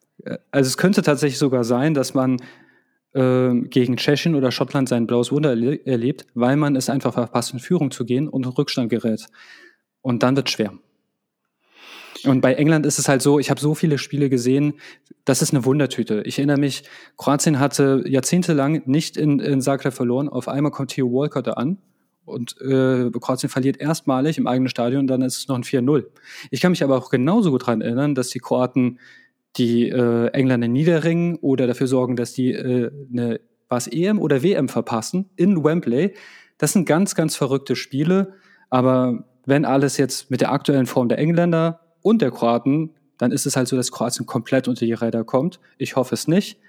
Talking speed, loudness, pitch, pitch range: 195 wpm, -20 LUFS, 135 Hz, 125-150 Hz